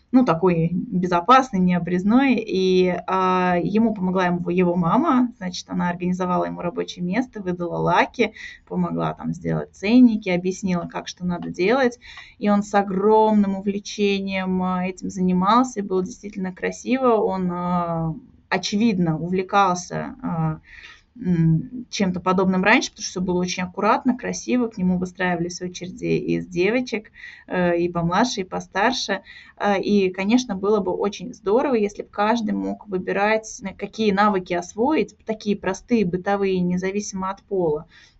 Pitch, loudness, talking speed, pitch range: 190 Hz, -22 LUFS, 125 wpm, 180-215 Hz